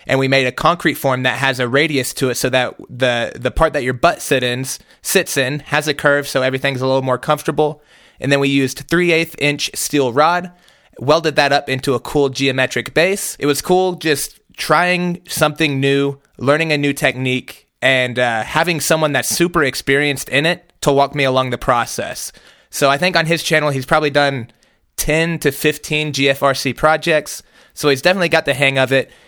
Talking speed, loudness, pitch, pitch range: 195 wpm, -16 LUFS, 145 Hz, 135-155 Hz